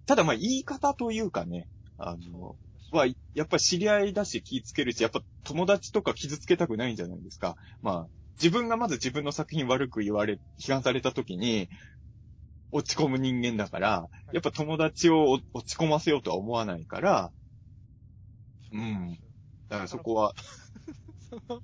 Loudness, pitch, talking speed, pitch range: -29 LUFS, 120 Hz, 315 characters per minute, 105-155 Hz